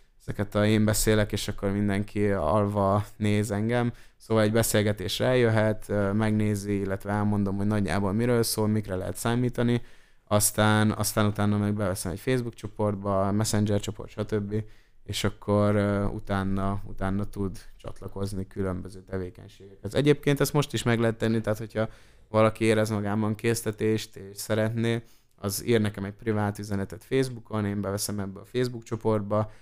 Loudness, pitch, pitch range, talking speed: -27 LUFS, 105 Hz, 100-110 Hz, 145 wpm